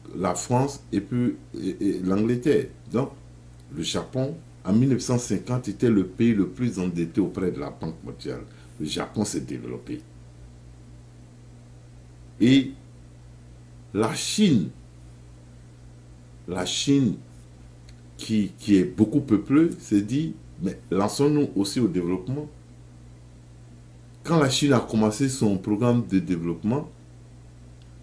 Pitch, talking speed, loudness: 90 Hz, 110 wpm, -25 LUFS